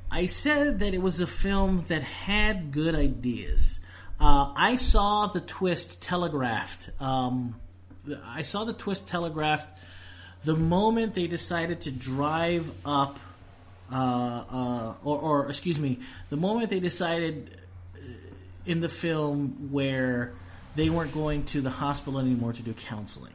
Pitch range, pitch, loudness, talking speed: 115-170 Hz, 145 Hz, -28 LUFS, 140 wpm